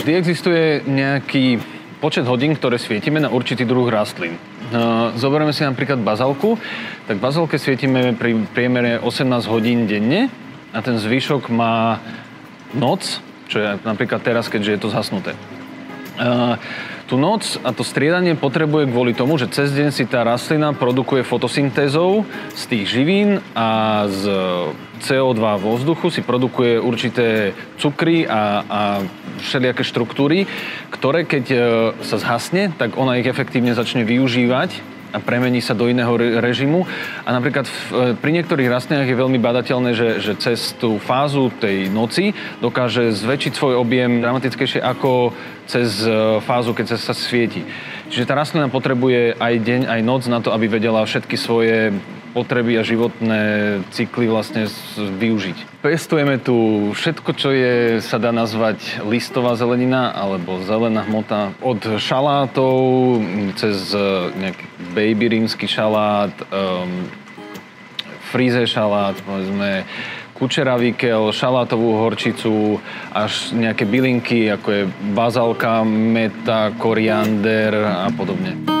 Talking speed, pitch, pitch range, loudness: 130 wpm, 120 Hz, 110-130 Hz, -18 LUFS